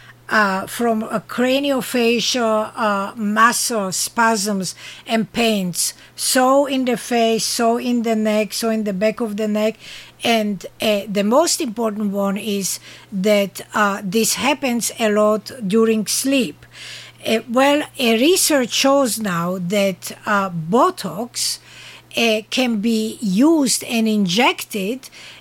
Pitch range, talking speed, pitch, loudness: 205-240 Hz, 130 wpm, 220 Hz, -18 LUFS